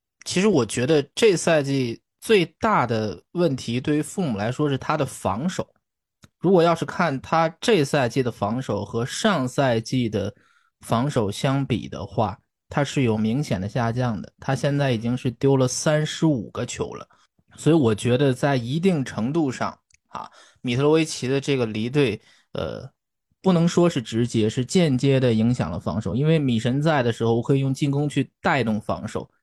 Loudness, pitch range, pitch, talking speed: -23 LUFS, 115-150 Hz, 135 Hz, 260 characters per minute